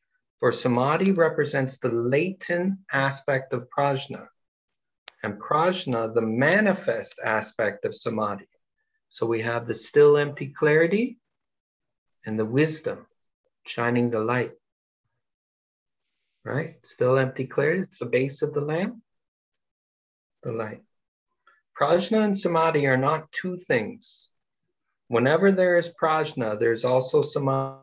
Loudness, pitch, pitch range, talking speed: -24 LUFS, 145 Hz, 130-185 Hz, 115 wpm